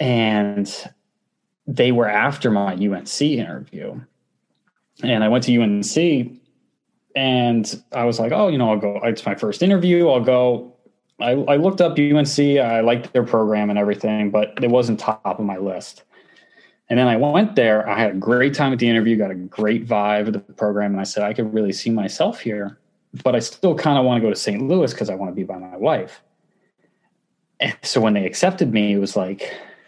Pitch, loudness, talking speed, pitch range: 115 Hz, -19 LUFS, 205 wpm, 105-130 Hz